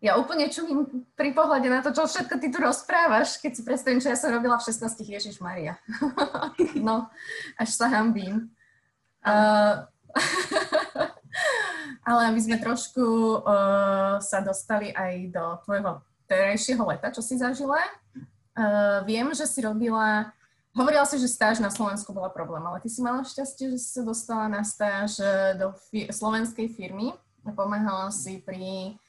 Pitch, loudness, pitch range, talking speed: 225 Hz, -26 LUFS, 200-270 Hz, 155 wpm